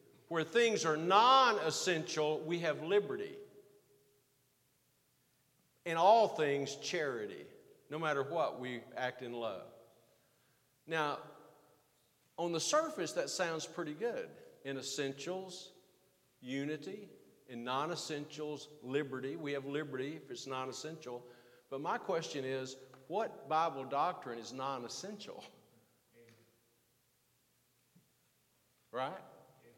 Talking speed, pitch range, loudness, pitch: 95 wpm, 130-175 Hz, -36 LUFS, 150 Hz